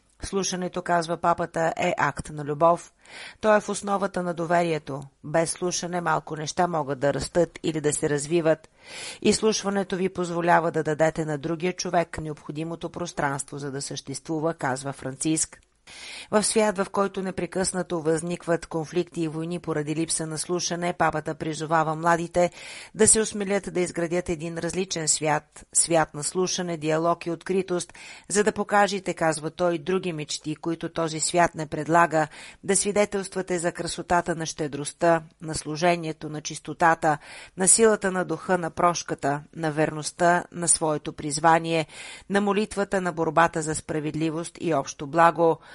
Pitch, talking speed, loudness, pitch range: 170 Hz, 145 wpm, -25 LUFS, 155-180 Hz